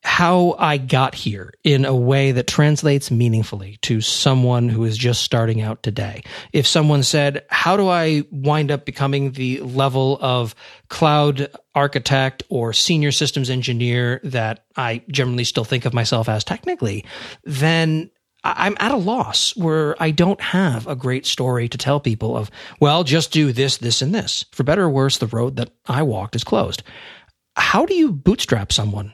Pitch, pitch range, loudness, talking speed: 135 Hz, 120-150 Hz, -18 LUFS, 175 wpm